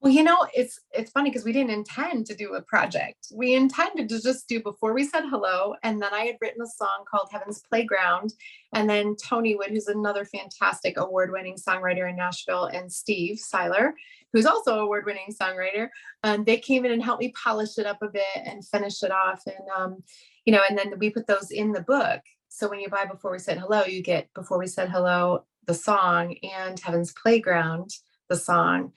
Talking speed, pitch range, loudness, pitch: 210 wpm, 185-230 Hz, -25 LUFS, 205 Hz